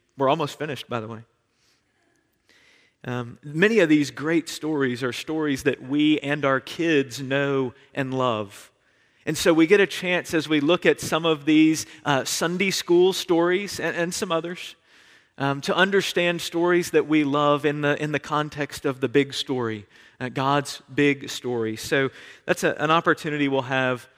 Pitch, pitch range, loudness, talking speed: 145 Hz, 135-165 Hz, -23 LUFS, 175 wpm